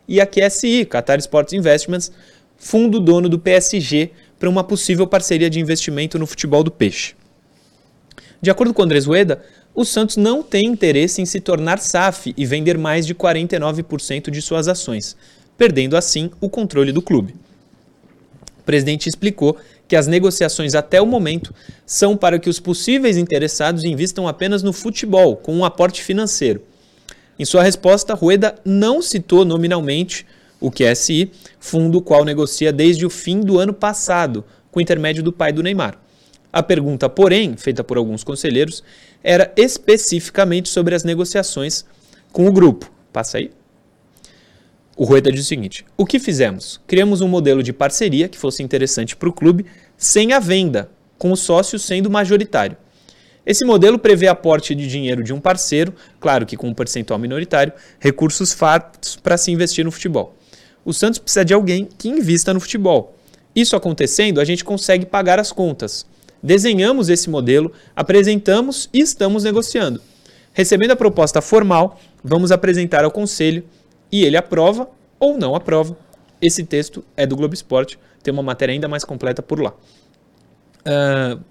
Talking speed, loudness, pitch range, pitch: 160 wpm, -16 LUFS, 150-195 Hz, 175 Hz